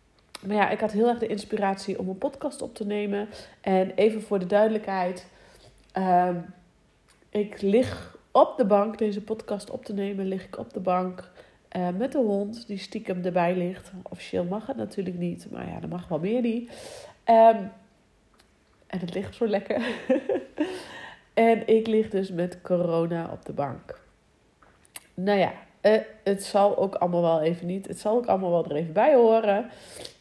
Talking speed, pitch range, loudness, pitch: 175 wpm, 185-220 Hz, -26 LUFS, 200 Hz